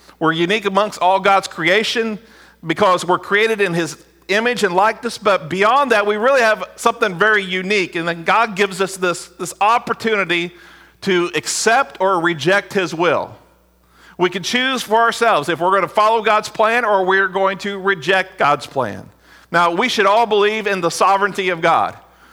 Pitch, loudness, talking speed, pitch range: 195 Hz, -16 LUFS, 175 wpm, 175-215 Hz